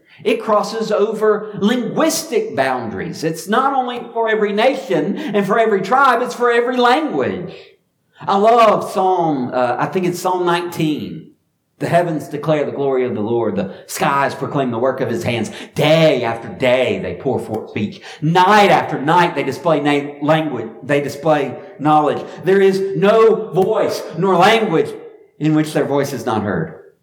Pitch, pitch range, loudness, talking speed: 180 Hz, 145-220 Hz, -16 LUFS, 165 wpm